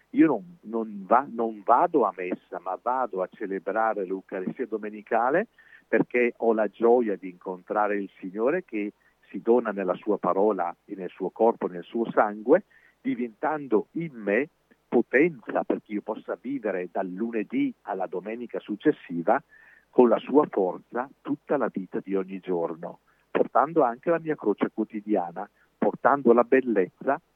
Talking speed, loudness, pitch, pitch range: 145 wpm, -26 LUFS, 110 Hz, 95-120 Hz